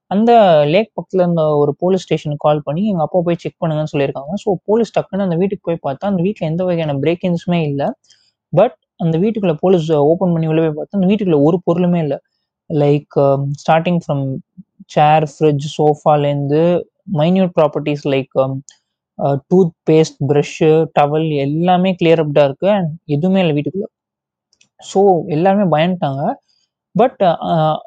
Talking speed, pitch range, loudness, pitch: 145 wpm, 150-185 Hz, -15 LUFS, 160 Hz